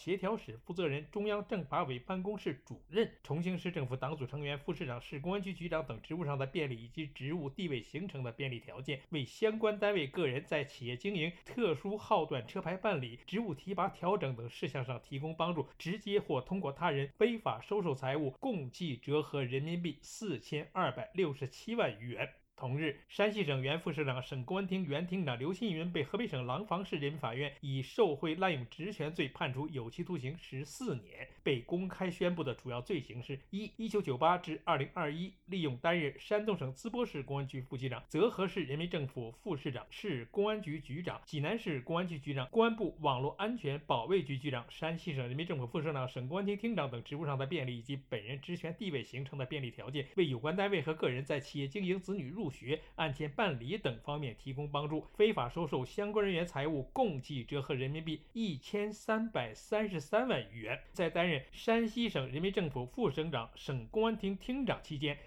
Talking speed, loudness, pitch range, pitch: 325 characters per minute, -37 LUFS, 135-190 Hz, 155 Hz